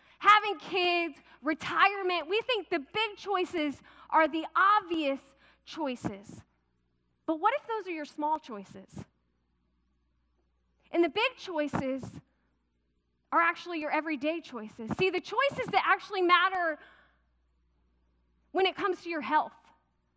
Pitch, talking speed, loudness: 310 Hz, 120 wpm, -29 LUFS